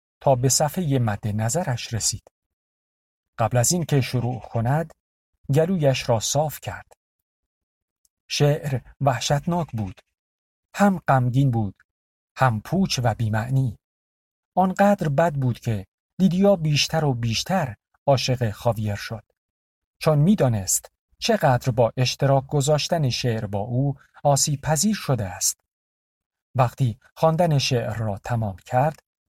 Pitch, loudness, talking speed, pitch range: 130 Hz, -22 LUFS, 115 wpm, 110-150 Hz